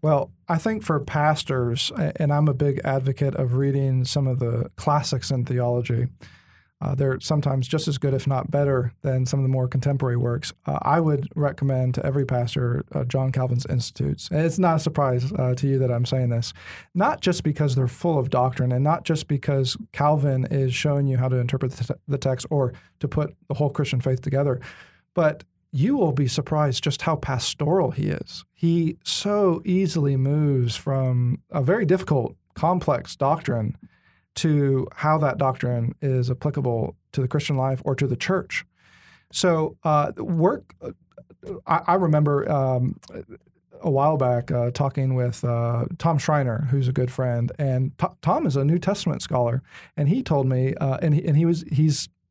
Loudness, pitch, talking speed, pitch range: -23 LUFS, 140 Hz, 180 wpm, 130-150 Hz